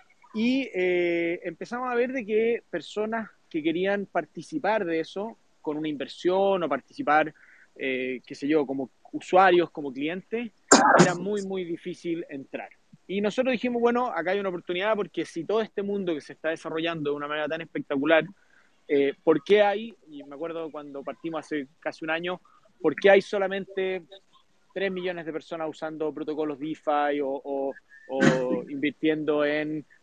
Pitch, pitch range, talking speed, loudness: 170 Hz, 150-200 Hz, 165 wpm, -27 LUFS